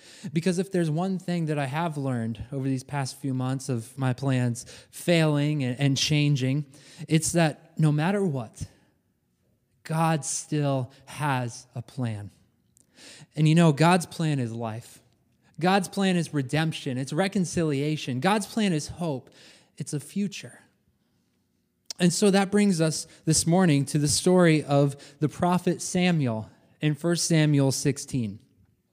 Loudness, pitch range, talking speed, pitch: -25 LUFS, 130-170 Hz, 140 wpm, 150 Hz